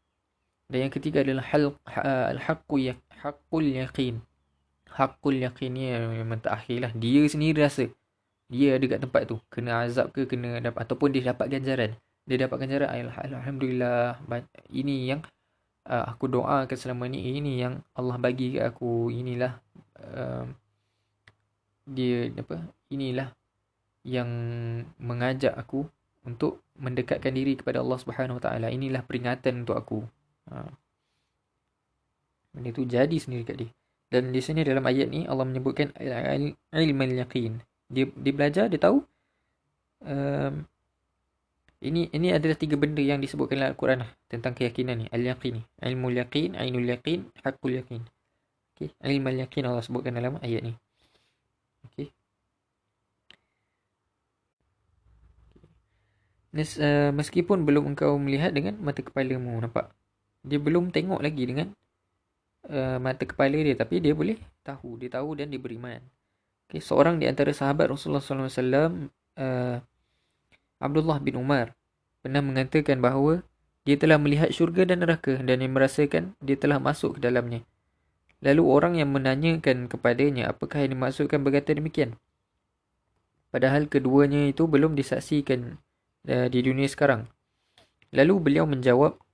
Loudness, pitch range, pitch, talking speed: -27 LUFS, 120-140 Hz, 130 Hz, 135 wpm